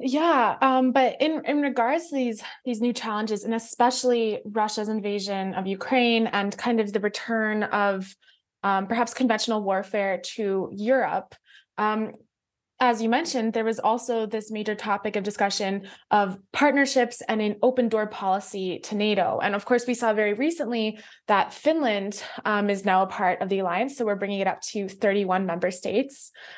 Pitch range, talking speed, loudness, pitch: 200-245 Hz, 170 wpm, -25 LUFS, 215 Hz